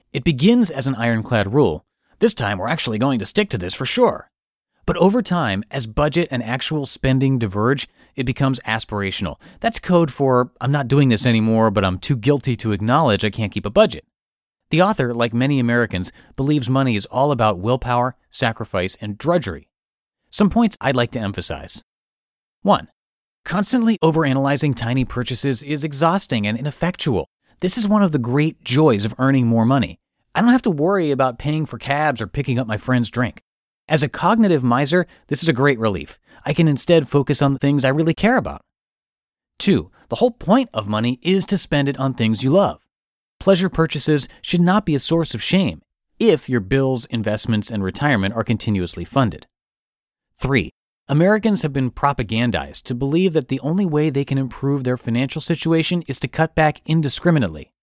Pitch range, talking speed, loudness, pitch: 120-160 Hz, 185 wpm, -19 LUFS, 135 Hz